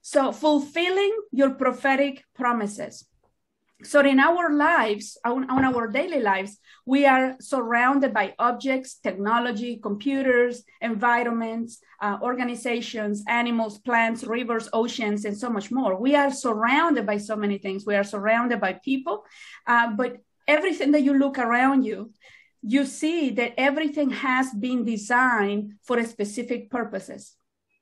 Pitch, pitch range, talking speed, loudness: 245 Hz, 225-275 Hz, 135 wpm, -23 LUFS